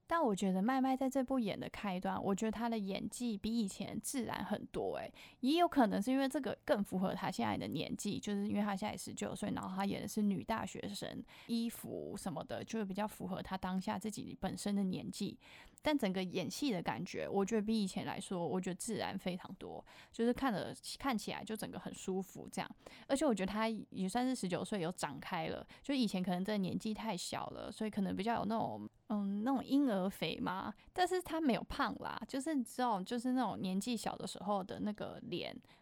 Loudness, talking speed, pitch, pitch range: -39 LUFS, 330 characters per minute, 215 Hz, 195-245 Hz